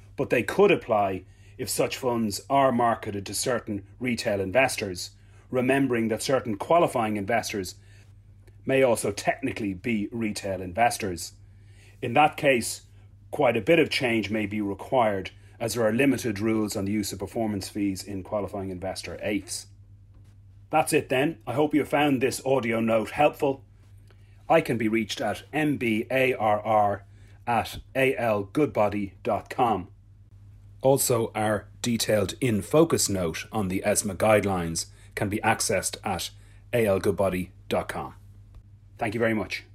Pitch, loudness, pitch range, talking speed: 105 Hz, -26 LUFS, 100-120 Hz, 135 wpm